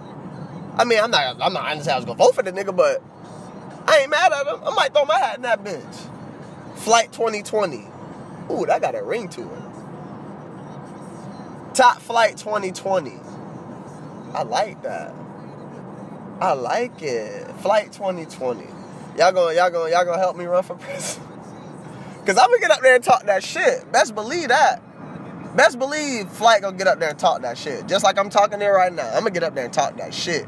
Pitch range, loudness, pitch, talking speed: 185-295 Hz, -20 LUFS, 215 Hz, 195 wpm